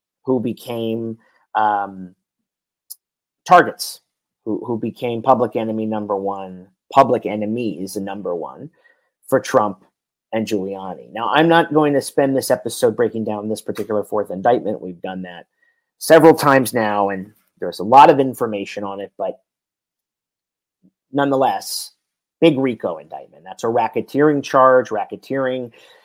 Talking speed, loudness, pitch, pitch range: 135 wpm, -18 LUFS, 115 Hz, 100-135 Hz